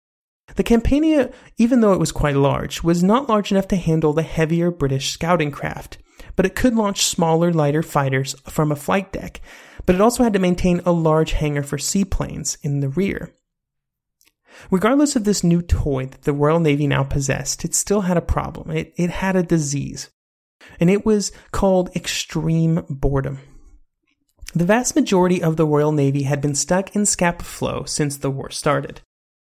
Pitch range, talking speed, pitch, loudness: 145-190 Hz, 180 wpm, 165 Hz, -19 LUFS